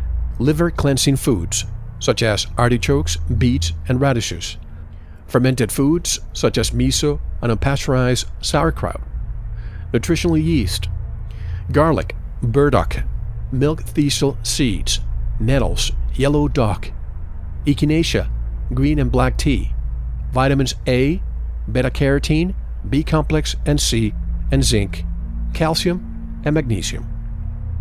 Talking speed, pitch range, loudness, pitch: 95 wpm, 85-140 Hz, -19 LUFS, 115 Hz